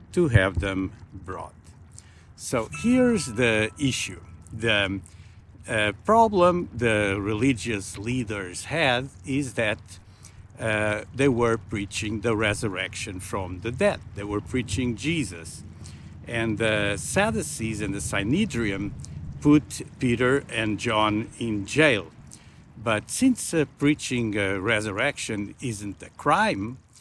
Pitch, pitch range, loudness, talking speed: 110 Hz, 100-125 Hz, -25 LUFS, 115 wpm